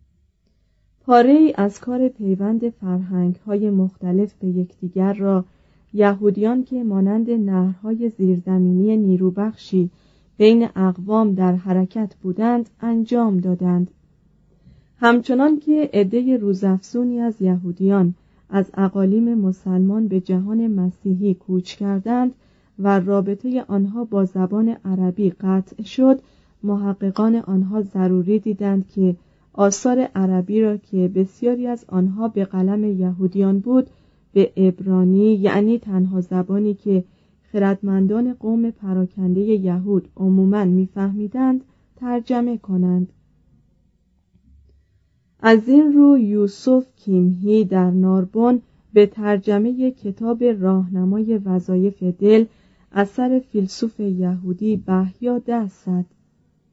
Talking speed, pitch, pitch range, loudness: 100 wpm, 200 Hz, 185-225 Hz, -19 LUFS